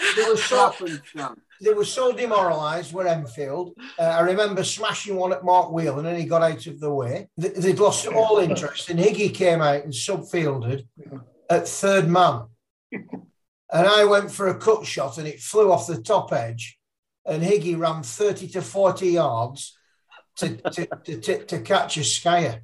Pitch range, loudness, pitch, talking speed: 150-195 Hz, -22 LUFS, 175 Hz, 180 wpm